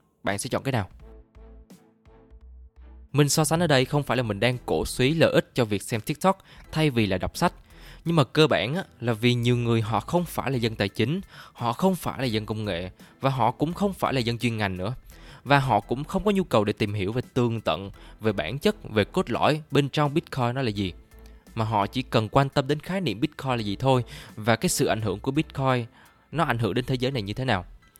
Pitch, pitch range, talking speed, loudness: 125 Hz, 110-145 Hz, 245 wpm, -25 LUFS